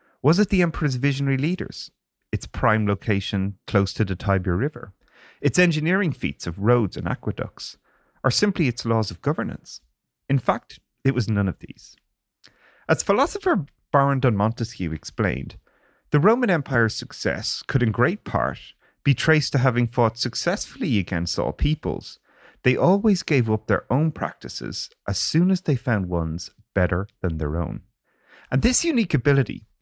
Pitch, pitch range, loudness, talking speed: 125 Hz, 100-155 Hz, -23 LUFS, 155 wpm